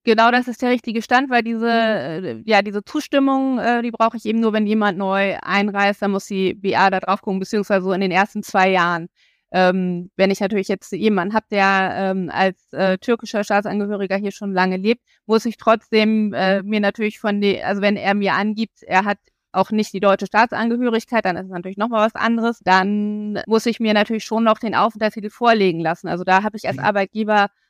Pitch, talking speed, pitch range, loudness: 205 Hz, 210 wpm, 195-225 Hz, -19 LUFS